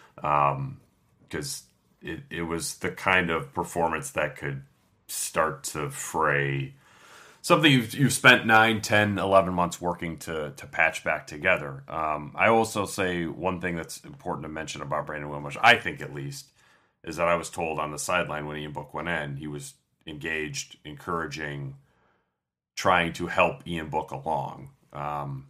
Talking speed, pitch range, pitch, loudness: 160 wpm, 70-90 Hz, 75 Hz, -26 LUFS